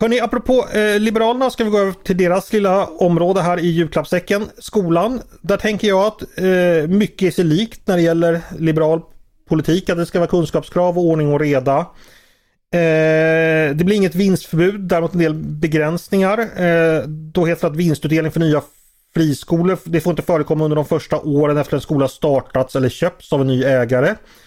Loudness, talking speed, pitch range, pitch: -17 LUFS, 190 wpm, 155-190 Hz, 170 Hz